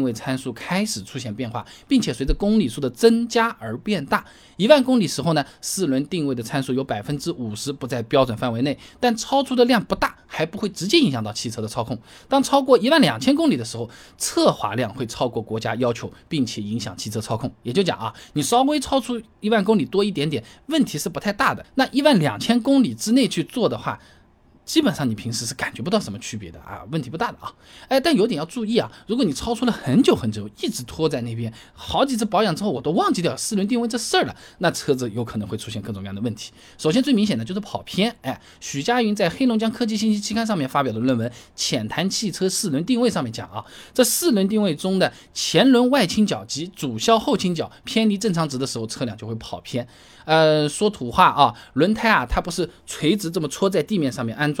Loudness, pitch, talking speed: -21 LUFS, 165 Hz, 350 characters per minute